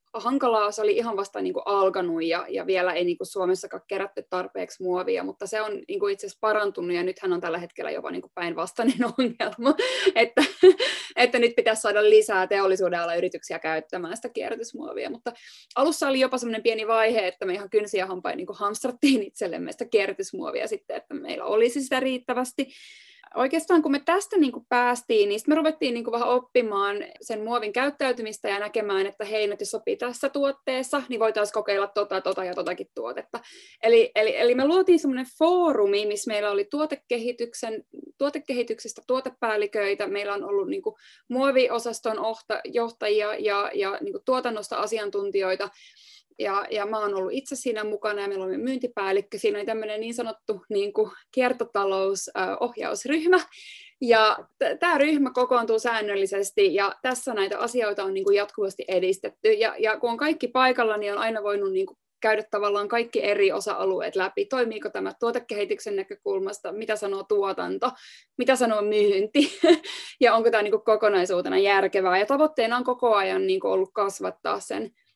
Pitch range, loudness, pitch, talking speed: 205-275 Hz, -25 LUFS, 230 Hz, 165 wpm